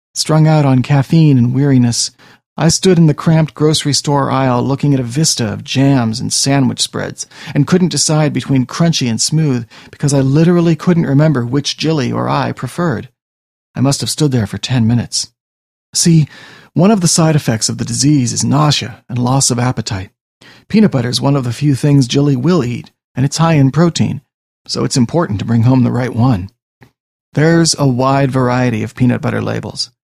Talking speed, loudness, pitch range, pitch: 190 wpm, -13 LUFS, 120-150 Hz, 135 Hz